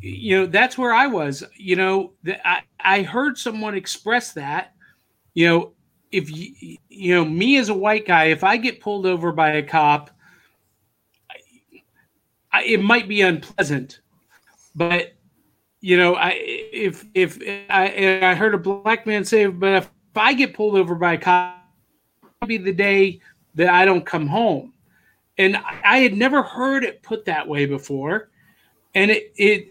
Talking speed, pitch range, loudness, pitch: 175 wpm, 180-215 Hz, -19 LUFS, 195 Hz